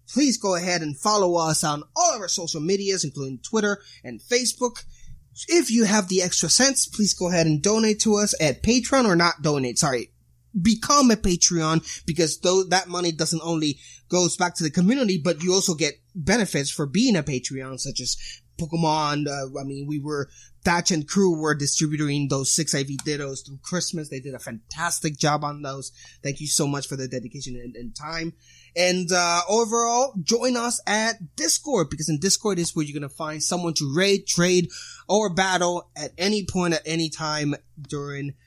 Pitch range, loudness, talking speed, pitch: 145-190 Hz, -22 LUFS, 190 wpm, 170 Hz